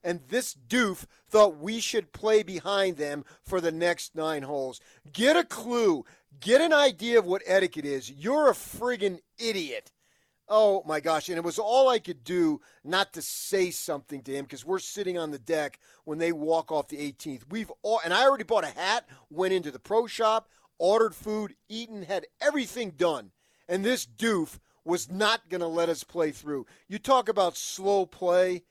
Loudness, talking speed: -27 LUFS, 190 wpm